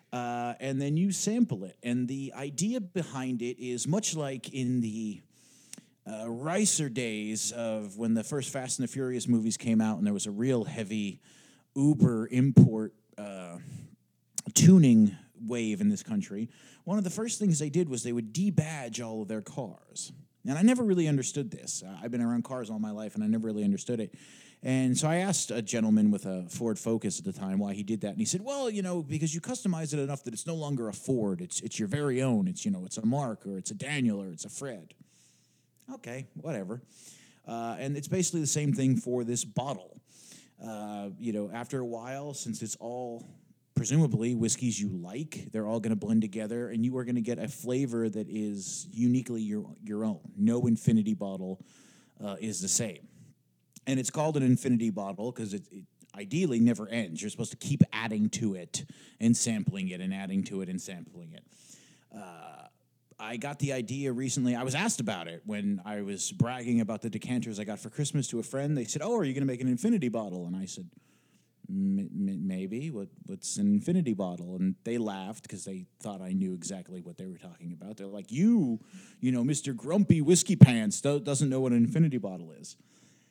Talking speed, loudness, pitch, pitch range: 210 wpm, -30 LUFS, 125 Hz, 110-160 Hz